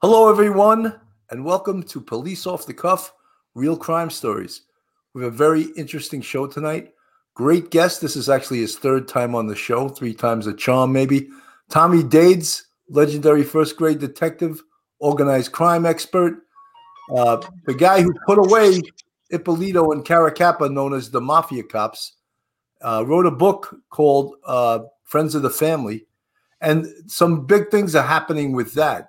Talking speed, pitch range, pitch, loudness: 155 wpm, 135-175 Hz, 155 Hz, -18 LUFS